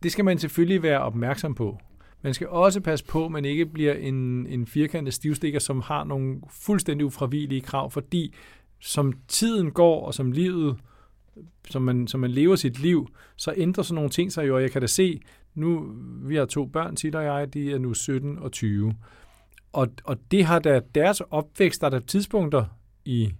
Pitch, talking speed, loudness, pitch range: 145 Hz, 200 wpm, -25 LUFS, 130-165 Hz